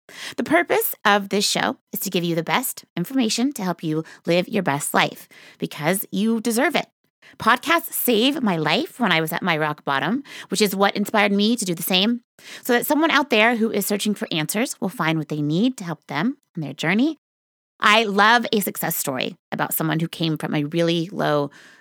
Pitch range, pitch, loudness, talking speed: 165-235 Hz, 205 Hz, -21 LUFS, 210 wpm